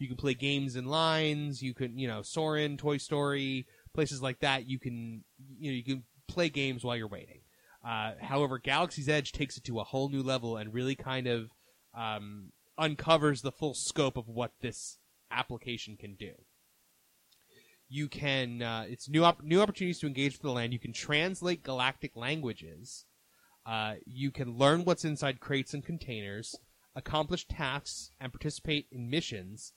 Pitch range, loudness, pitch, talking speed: 120-150 Hz, -33 LUFS, 135 Hz, 175 wpm